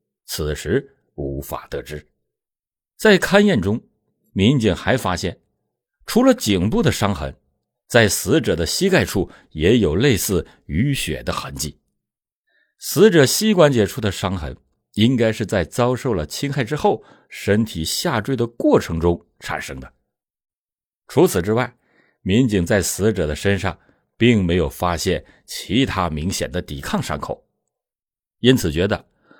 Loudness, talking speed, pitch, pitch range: -19 LUFS, 200 characters per minute, 100 Hz, 75-125 Hz